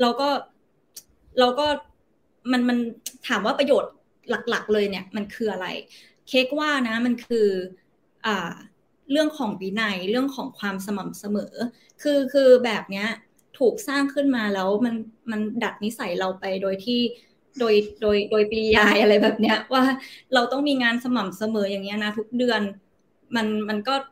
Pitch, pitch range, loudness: 225 Hz, 210-255 Hz, -23 LUFS